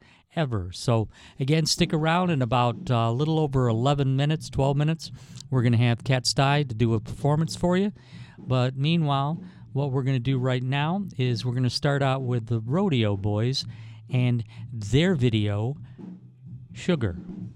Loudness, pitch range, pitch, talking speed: -25 LUFS, 120-150 Hz, 130 Hz, 170 wpm